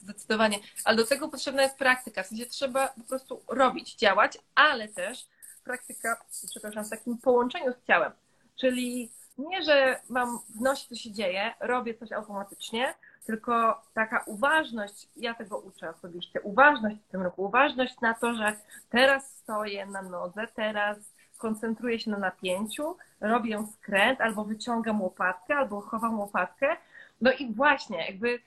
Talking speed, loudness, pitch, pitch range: 150 wpm, -28 LUFS, 230 Hz, 210-255 Hz